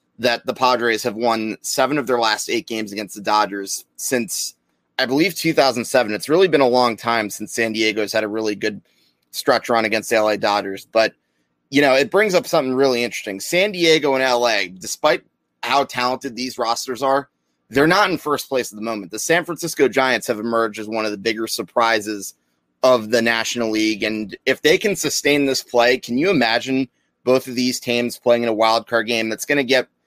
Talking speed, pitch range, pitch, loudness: 210 wpm, 110-130 Hz, 115 Hz, -19 LUFS